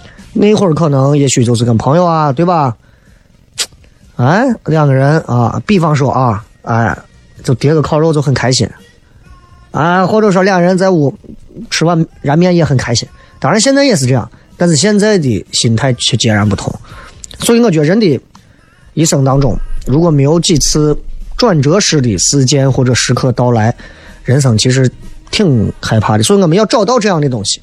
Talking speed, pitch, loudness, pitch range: 265 characters per minute, 140 Hz, -11 LUFS, 125-175 Hz